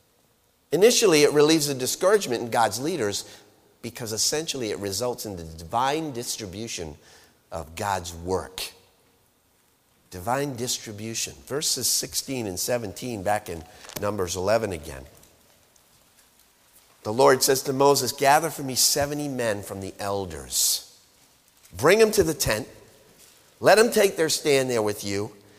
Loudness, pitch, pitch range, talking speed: -23 LUFS, 115 Hz, 100-140 Hz, 130 wpm